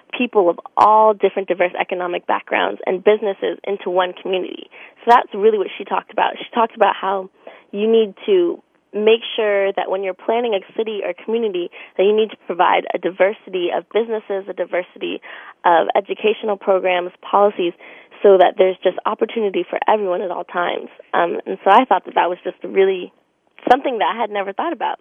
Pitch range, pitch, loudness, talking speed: 185-230 Hz, 205 Hz, -18 LUFS, 195 wpm